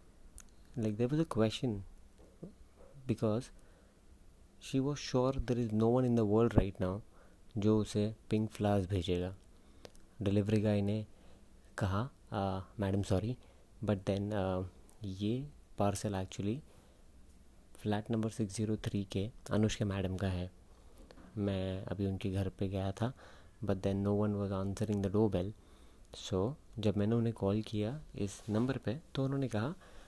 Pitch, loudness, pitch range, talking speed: 100 Hz, -36 LUFS, 95-110 Hz, 145 wpm